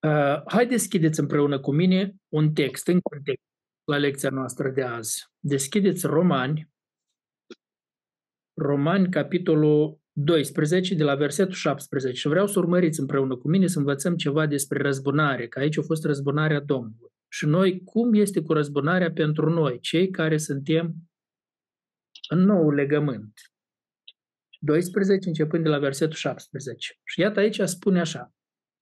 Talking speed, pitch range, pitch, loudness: 140 wpm, 145-175 Hz, 155 Hz, -24 LUFS